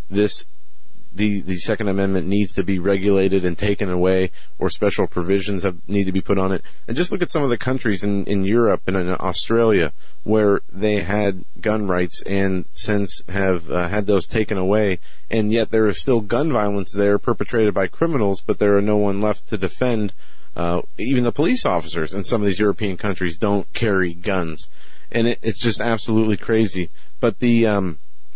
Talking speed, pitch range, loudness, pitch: 195 wpm, 95-110 Hz, -20 LUFS, 100 Hz